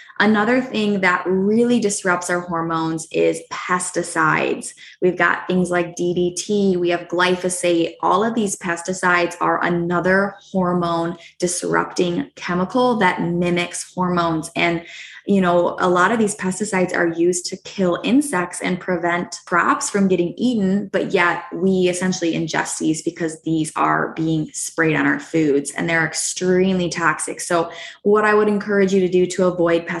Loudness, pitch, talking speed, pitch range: -19 LUFS, 180 Hz, 155 wpm, 170-190 Hz